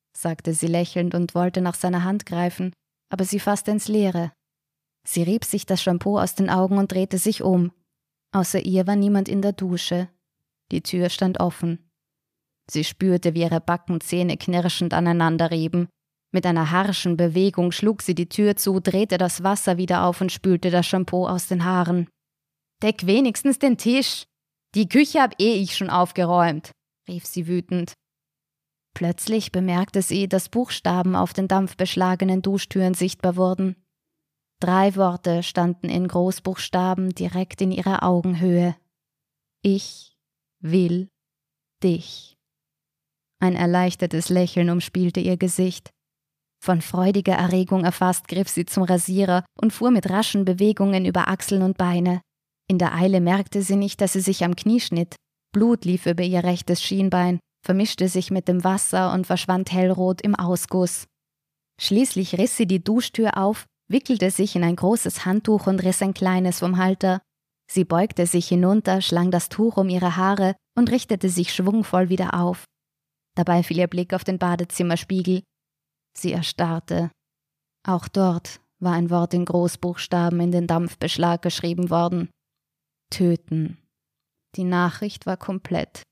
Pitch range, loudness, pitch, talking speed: 175-195 Hz, -22 LUFS, 185 Hz, 150 wpm